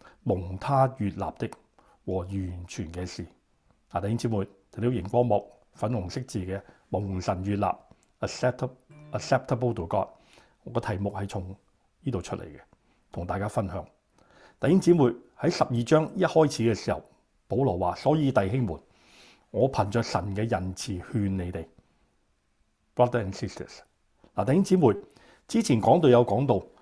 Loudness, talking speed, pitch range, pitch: -27 LUFS, 290 characters per minute, 95-125 Hz, 110 Hz